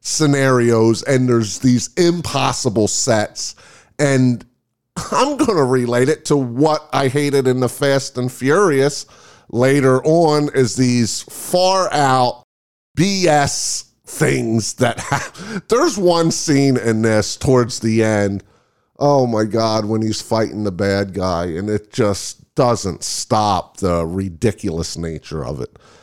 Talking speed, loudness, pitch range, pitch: 135 wpm, -17 LUFS, 105-140 Hz, 125 Hz